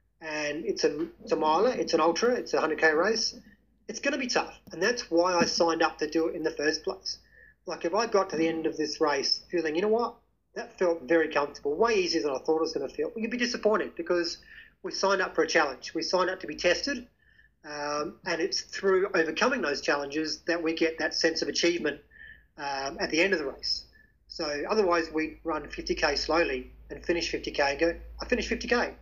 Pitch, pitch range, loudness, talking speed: 170 Hz, 155-230 Hz, -28 LUFS, 225 wpm